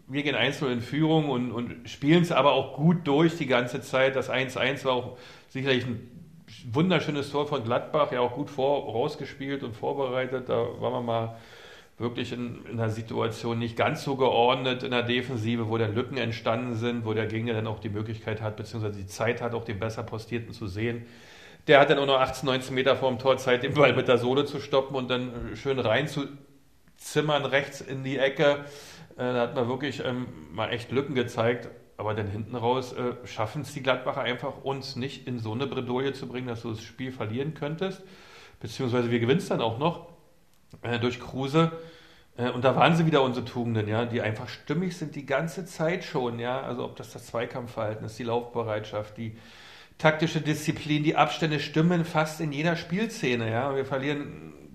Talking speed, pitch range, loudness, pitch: 195 wpm, 120-145 Hz, -27 LUFS, 130 Hz